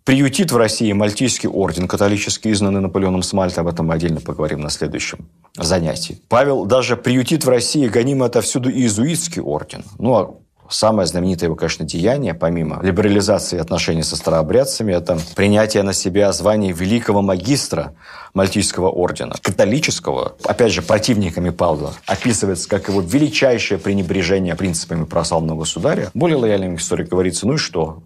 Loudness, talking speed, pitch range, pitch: -17 LUFS, 145 wpm, 85-110 Hz, 95 Hz